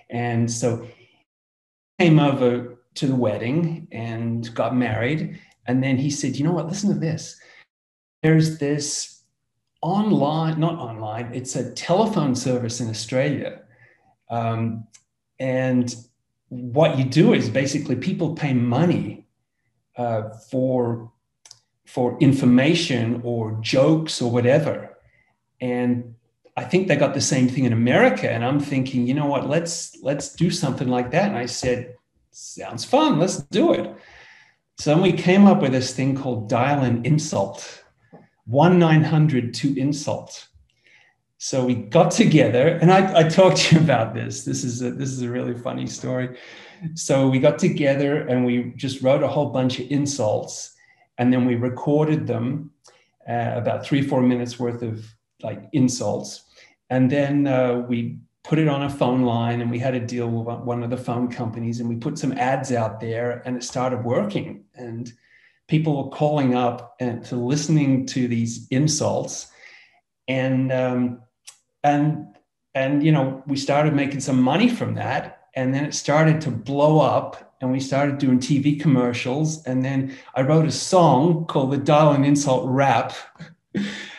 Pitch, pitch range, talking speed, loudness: 130 Hz, 120-150 Hz, 160 wpm, -21 LUFS